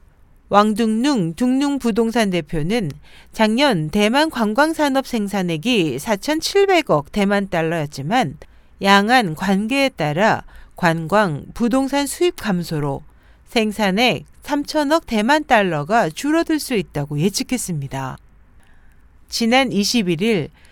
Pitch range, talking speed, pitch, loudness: 165-260 Hz, 210 characters per minute, 210 Hz, -18 LUFS